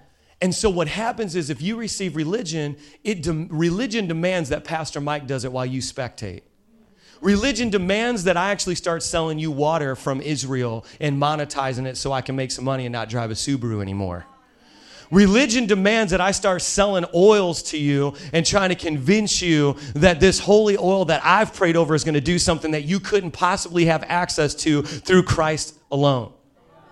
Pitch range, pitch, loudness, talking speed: 145-190 Hz, 165 Hz, -21 LUFS, 185 wpm